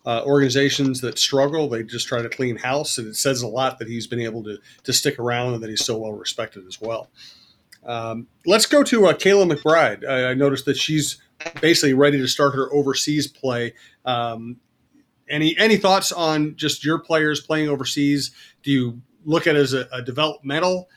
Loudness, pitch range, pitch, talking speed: -20 LUFS, 120-155 Hz, 140 Hz, 195 wpm